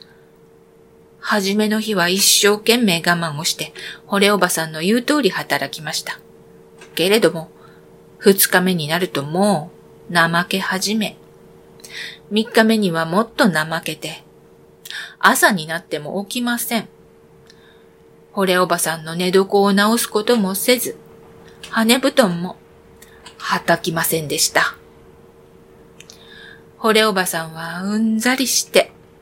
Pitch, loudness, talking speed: 170 Hz, -17 LUFS, 230 characters per minute